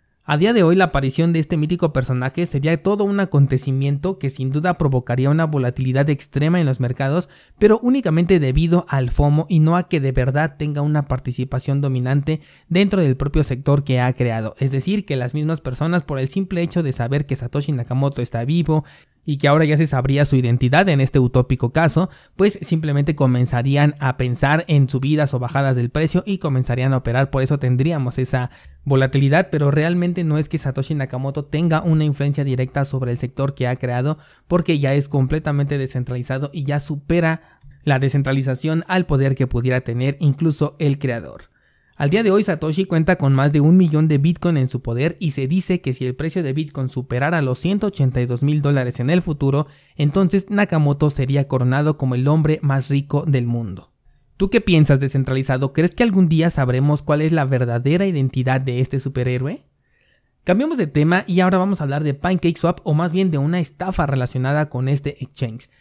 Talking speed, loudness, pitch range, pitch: 195 wpm, -19 LUFS, 130-165 Hz, 145 Hz